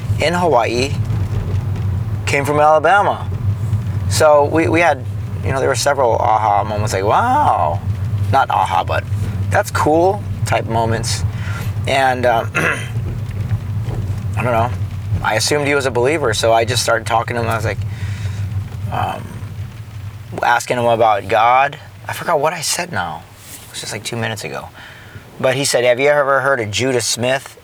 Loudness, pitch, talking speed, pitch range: -16 LUFS, 110 Hz, 160 wpm, 105-120 Hz